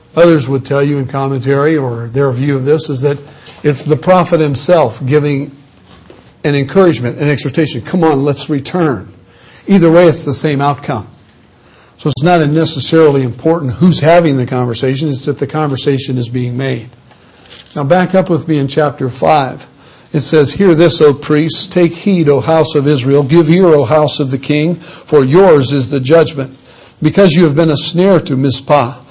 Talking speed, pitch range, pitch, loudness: 180 wpm, 135-160 Hz, 145 Hz, -11 LUFS